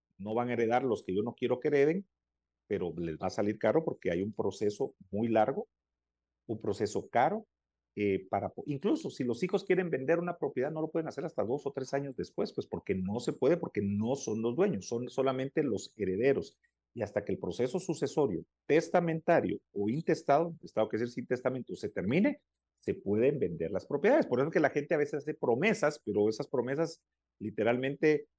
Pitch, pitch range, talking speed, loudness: 125 Hz, 105-155 Hz, 205 wpm, -32 LUFS